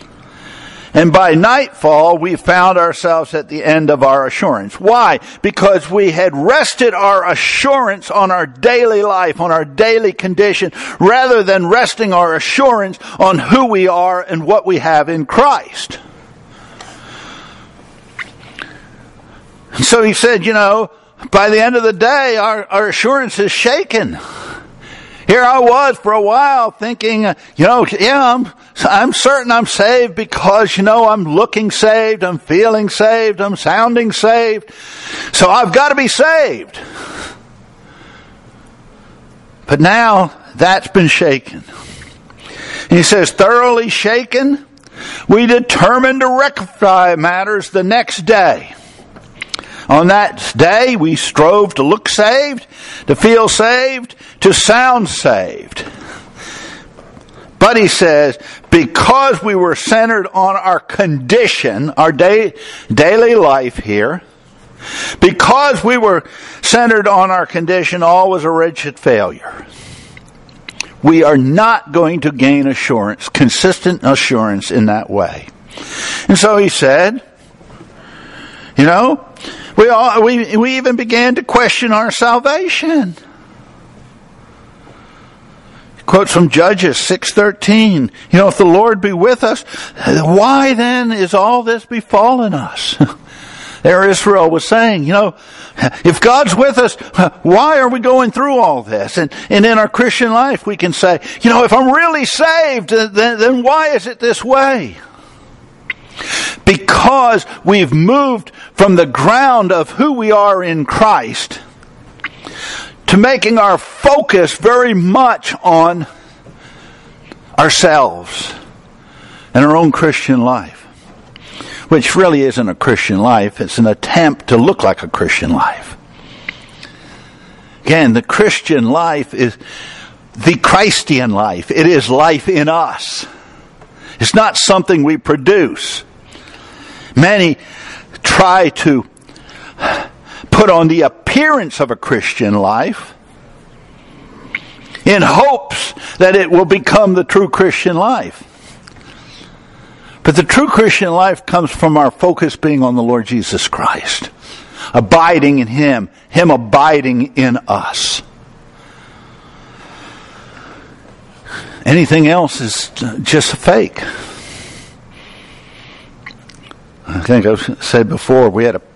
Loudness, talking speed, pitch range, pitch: -10 LUFS, 125 wpm, 165-240 Hz, 205 Hz